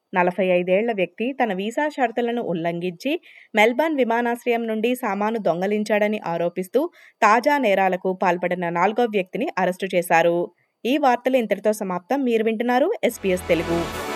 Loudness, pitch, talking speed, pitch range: -22 LUFS, 210 Hz, 105 wpm, 180-240 Hz